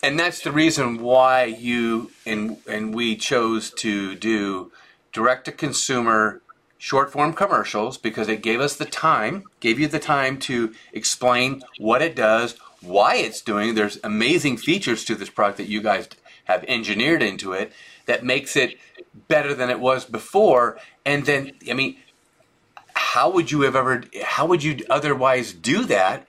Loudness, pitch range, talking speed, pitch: -21 LUFS, 110-145 Hz, 165 wpm, 125 Hz